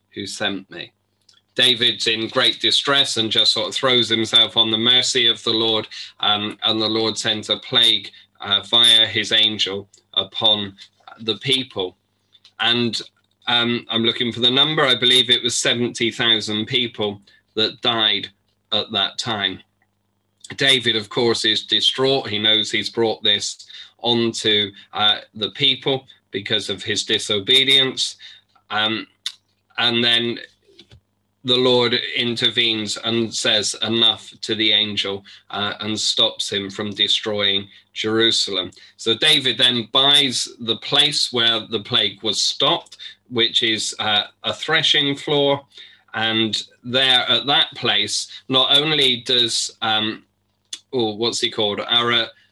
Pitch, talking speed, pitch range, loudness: 115 Hz, 135 wpm, 105-125 Hz, -17 LUFS